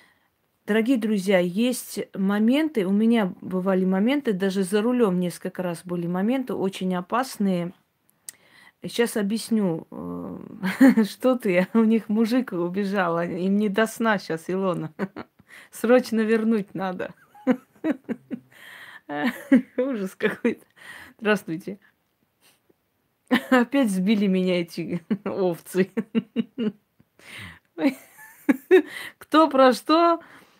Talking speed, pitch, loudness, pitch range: 90 wpm, 215 Hz, -23 LUFS, 185-245 Hz